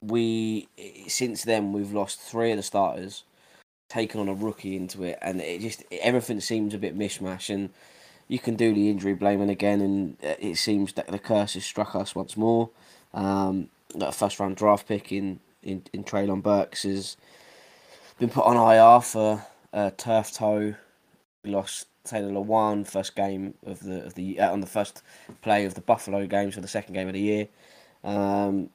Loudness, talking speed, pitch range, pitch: -26 LUFS, 190 wpm, 95-110 Hz, 100 Hz